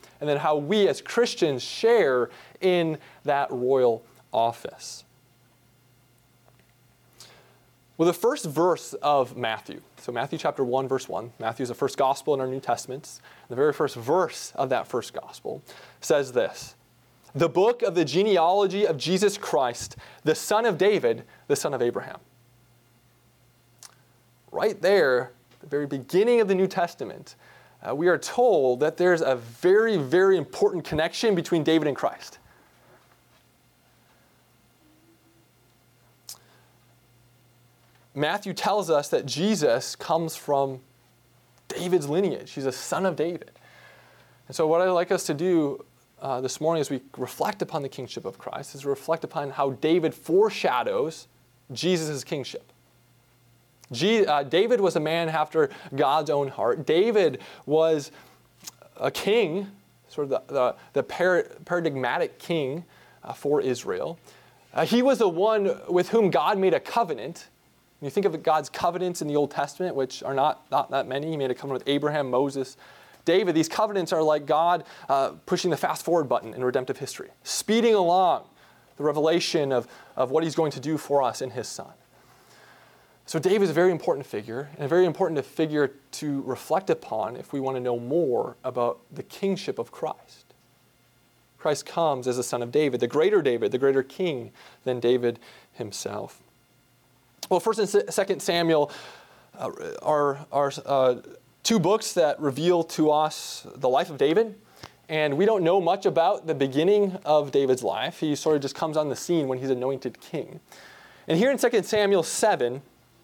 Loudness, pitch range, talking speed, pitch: -25 LUFS, 130-185 Hz, 160 wpm, 150 Hz